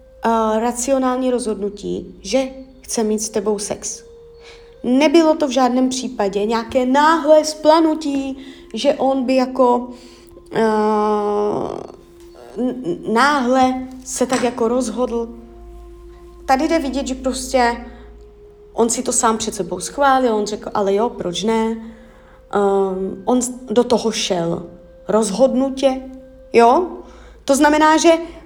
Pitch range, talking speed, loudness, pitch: 220-275 Hz, 120 wpm, -17 LUFS, 250 Hz